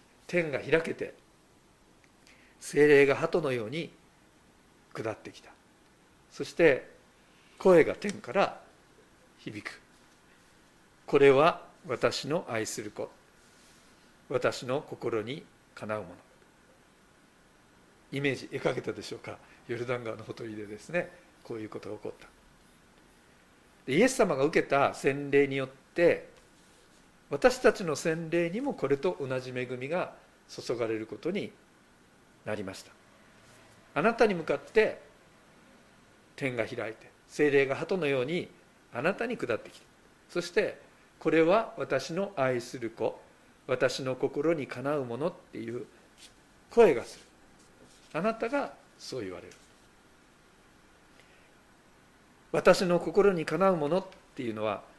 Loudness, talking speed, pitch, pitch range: -29 LUFS, 230 characters per minute, 145 Hz, 125-185 Hz